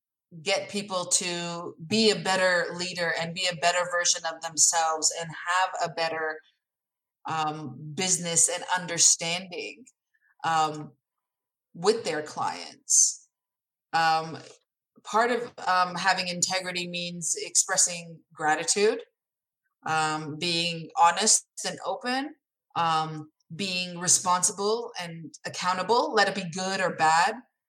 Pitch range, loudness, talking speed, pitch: 165-190 Hz, -25 LUFS, 110 wpm, 175 Hz